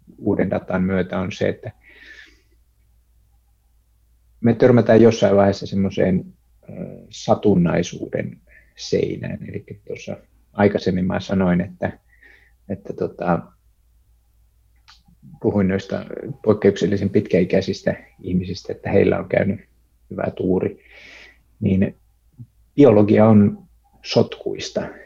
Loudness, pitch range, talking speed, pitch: -19 LUFS, 85-110 Hz, 85 wpm, 95 Hz